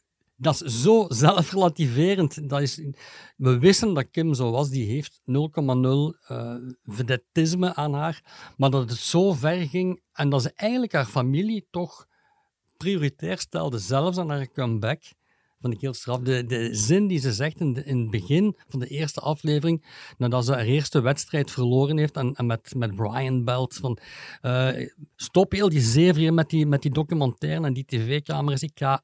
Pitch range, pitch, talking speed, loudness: 130-165 Hz, 145 Hz, 170 wpm, -24 LUFS